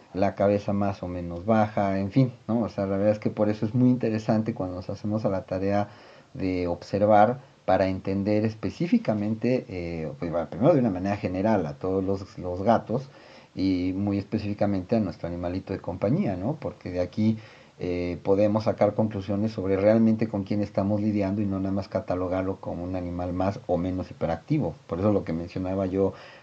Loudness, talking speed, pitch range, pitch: -26 LUFS, 190 wpm, 95-110 Hz, 100 Hz